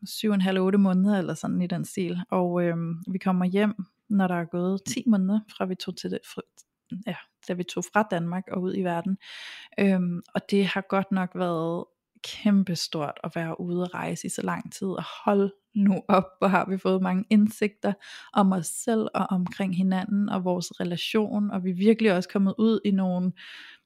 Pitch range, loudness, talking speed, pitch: 180-205 Hz, -26 LUFS, 200 wpm, 190 Hz